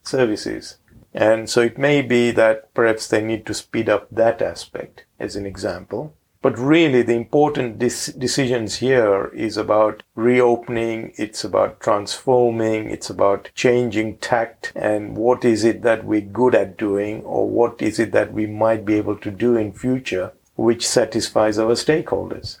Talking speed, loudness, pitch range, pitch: 160 wpm, -19 LUFS, 110-125 Hz, 115 Hz